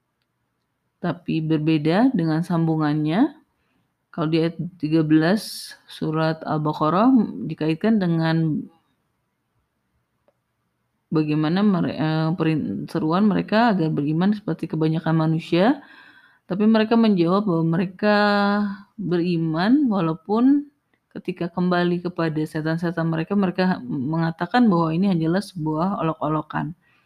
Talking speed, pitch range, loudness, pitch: 85 wpm, 160-205 Hz, -21 LUFS, 170 Hz